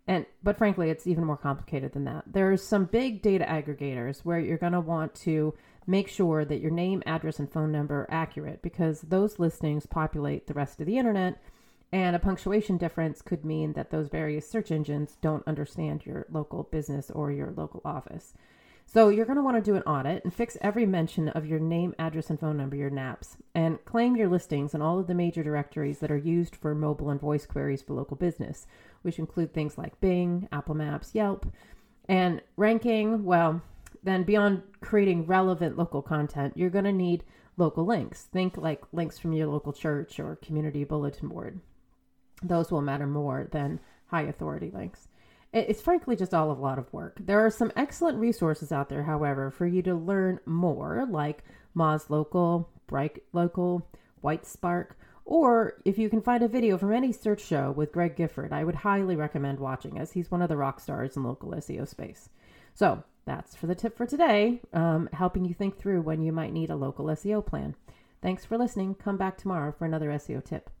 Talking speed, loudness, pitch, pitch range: 200 wpm, -29 LUFS, 165 Hz, 150-190 Hz